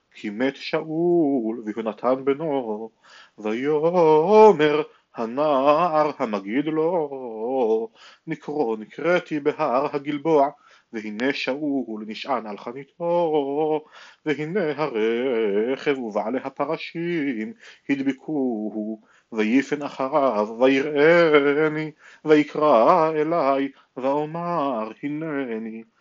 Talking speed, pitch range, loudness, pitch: 70 wpm, 125-155 Hz, -22 LUFS, 145 Hz